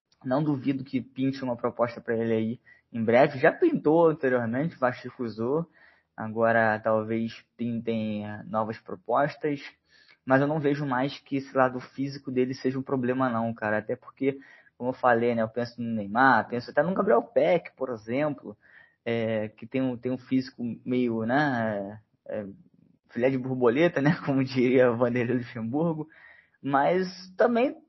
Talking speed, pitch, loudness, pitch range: 155 wpm, 125 Hz, -27 LUFS, 115-140 Hz